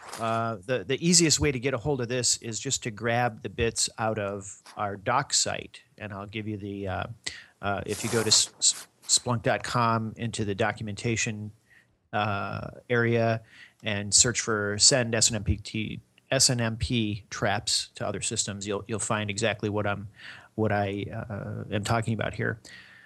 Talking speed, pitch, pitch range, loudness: 165 wpm, 110 Hz, 105-115 Hz, -26 LUFS